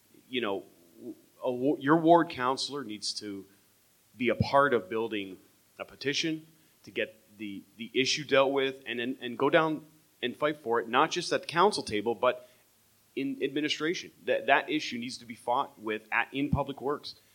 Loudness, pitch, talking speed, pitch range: -29 LUFS, 135 Hz, 180 wpm, 110-150 Hz